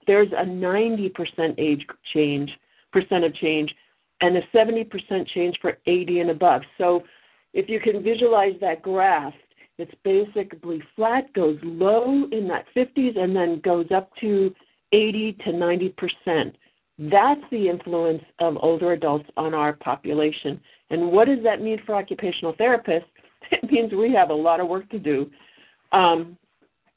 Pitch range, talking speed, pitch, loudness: 165-215 Hz, 145 wpm, 185 Hz, -22 LUFS